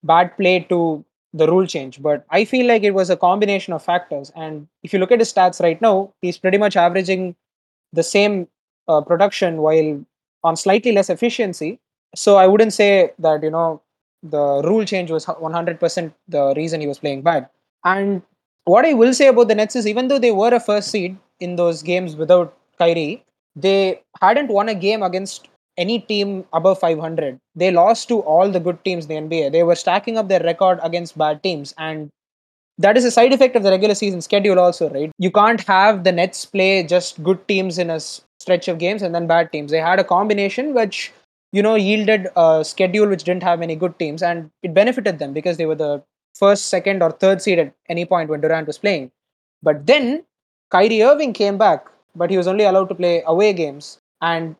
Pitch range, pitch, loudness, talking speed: 165-205 Hz, 180 Hz, -17 LUFS, 210 wpm